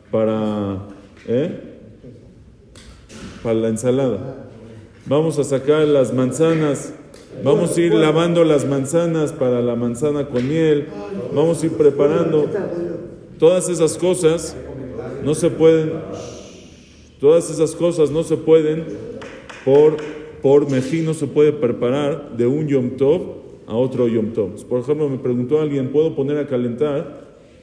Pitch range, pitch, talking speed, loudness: 125-160 Hz, 145 Hz, 125 wpm, -18 LUFS